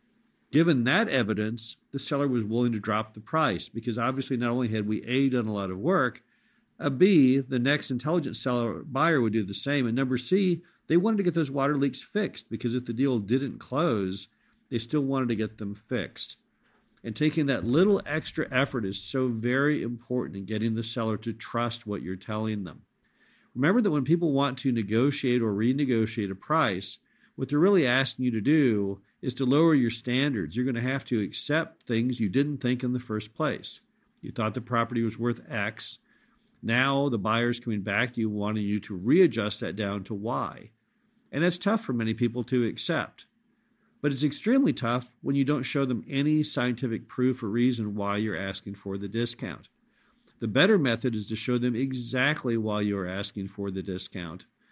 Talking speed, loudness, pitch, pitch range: 195 wpm, -27 LUFS, 125 Hz, 110-140 Hz